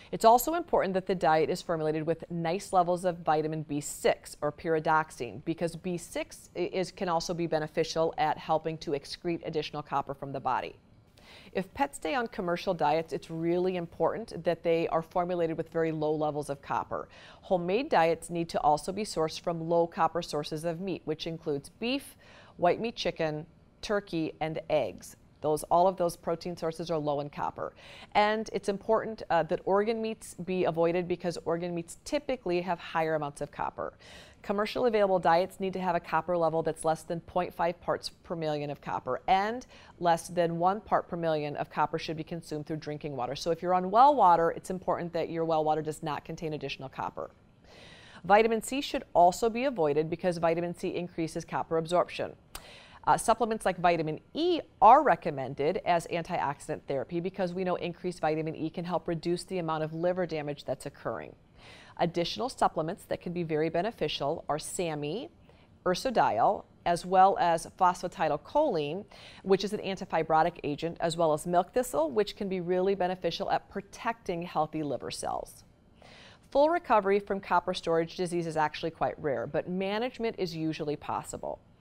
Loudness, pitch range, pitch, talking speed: -30 LUFS, 160-185 Hz, 170 Hz, 175 wpm